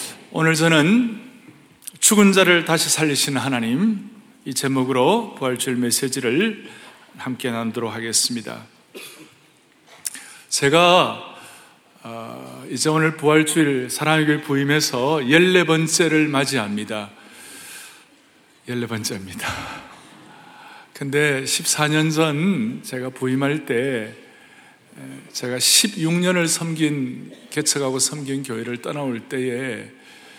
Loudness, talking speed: -19 LUFS, 200 characters per minute